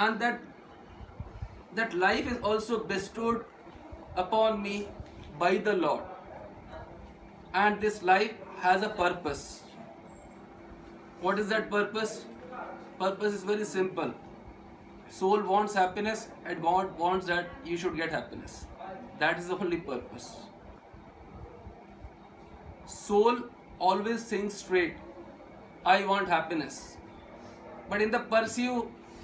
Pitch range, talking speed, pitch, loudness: 185-220 Hz, 110 wpm, 205 Hz, -30 LUFS